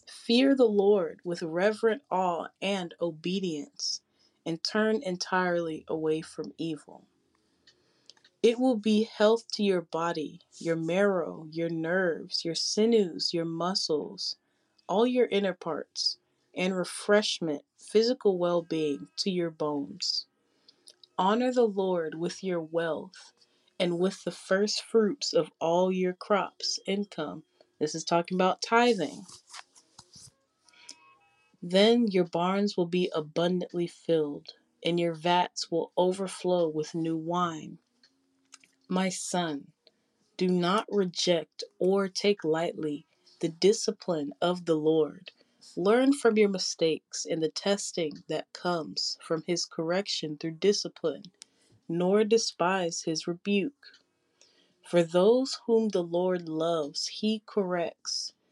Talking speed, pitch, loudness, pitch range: 120 wpm, 180 Hz, -28 LUFS, 165-205 Hz